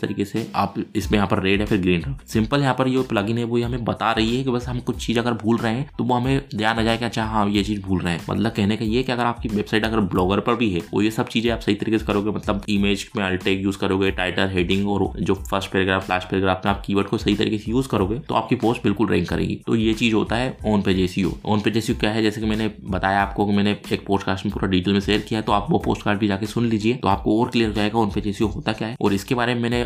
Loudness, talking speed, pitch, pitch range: -22 LUFS, 285 wpm, 105 Hz, 100-115 Hz